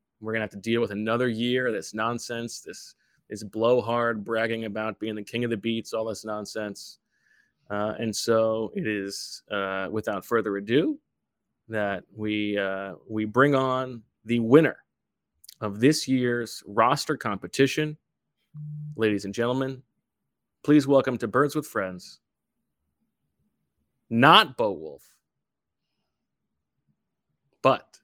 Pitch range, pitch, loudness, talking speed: 105-130 Hz, 115 Hz, -25 LUFS, 130 wpm